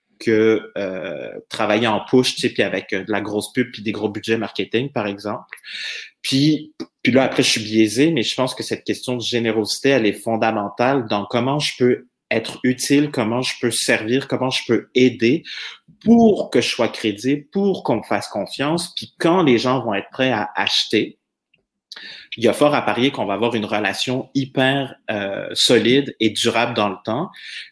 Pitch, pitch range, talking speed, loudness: 120 Hz, 110-135 Hz, 195 wpm, -19 LUFS